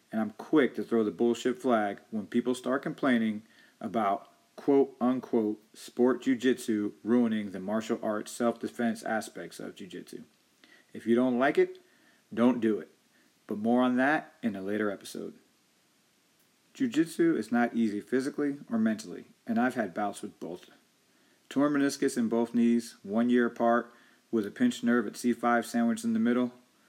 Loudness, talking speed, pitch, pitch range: -29 LUFS, 160 wpm, 120 Hz, 115-145 Hz